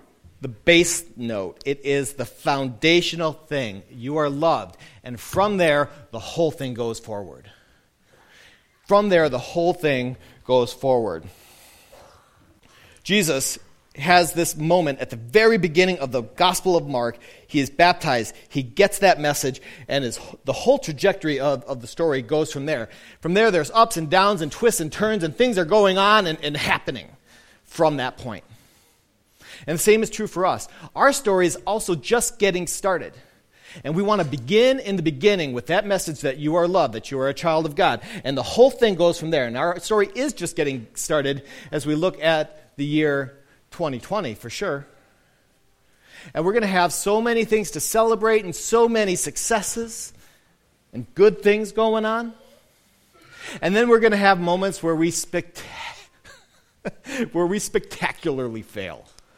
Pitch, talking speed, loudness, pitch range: 165 Hz, 175 wpm, -21 LUFS, 140-200 Hz